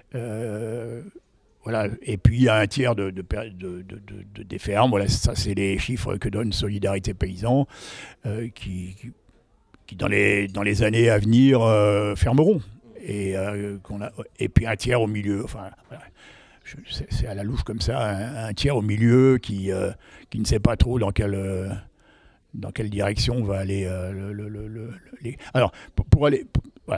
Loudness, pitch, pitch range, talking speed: -23 LUFS, 105 Hz, 100-115 Hz, 200 wpm